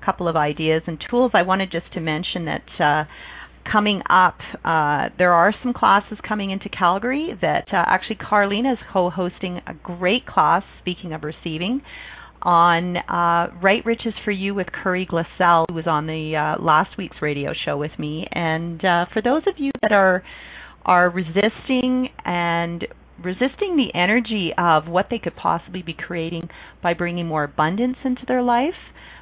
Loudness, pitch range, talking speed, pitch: -20 LUFS, 170-215 Hz, 170 wpm, 180 Hz